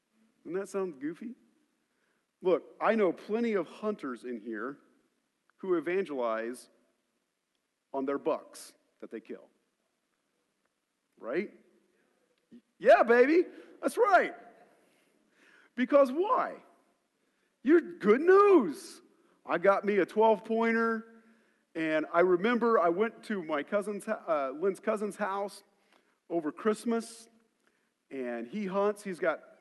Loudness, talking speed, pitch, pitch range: -29 LUFS, 110 wpm, 220 Hz, 190-250 Hz